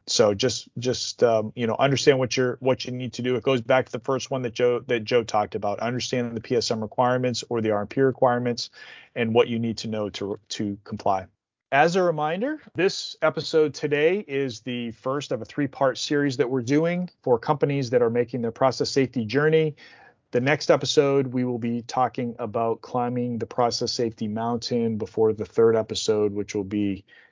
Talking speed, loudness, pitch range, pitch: 200 wpm, -24 LUFS, 115-135 Hz, 125 Hz